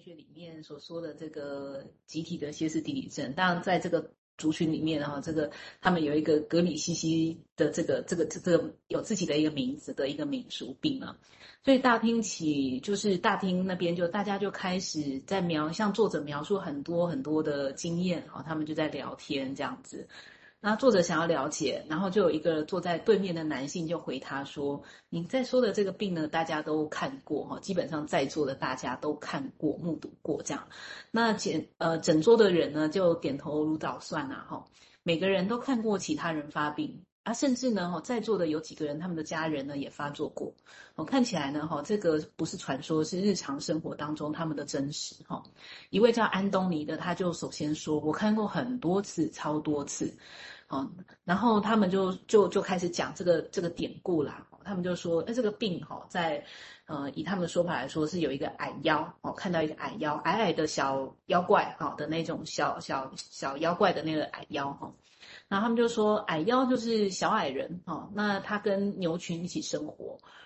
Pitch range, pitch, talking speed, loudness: 155-195 Hz, 165 Hz, 295 characters per minute, -30 LUFS